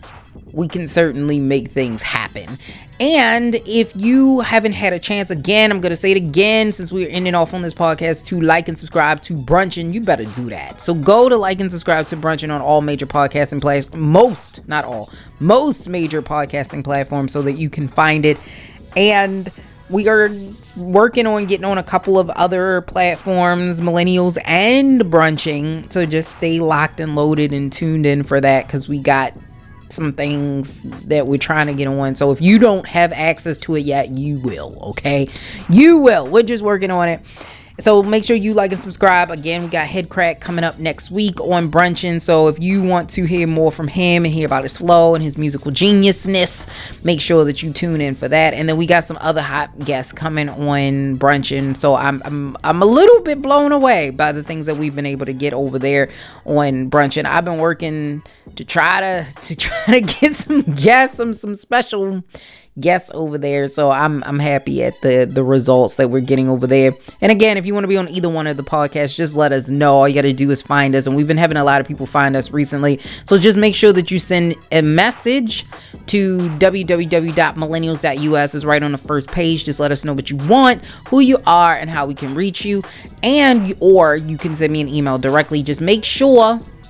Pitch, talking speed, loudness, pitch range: 160 Hz, 215 wpm, -15 LUFS, 145-190 Hz